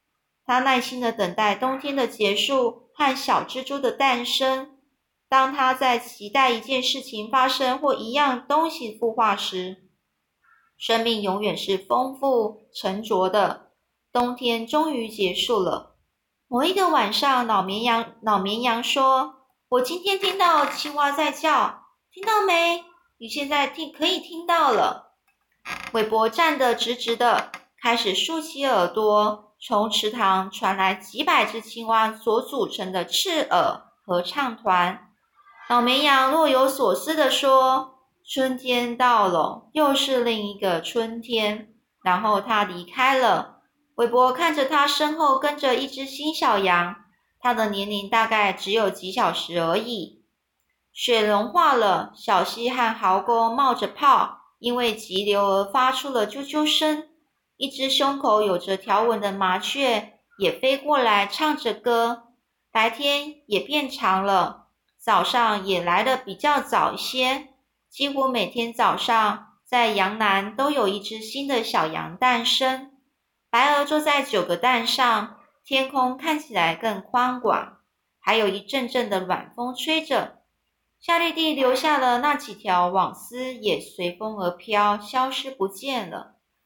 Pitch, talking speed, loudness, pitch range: 245 Hz, 205 characters per minute, -22 LUFS, 210-275 Hz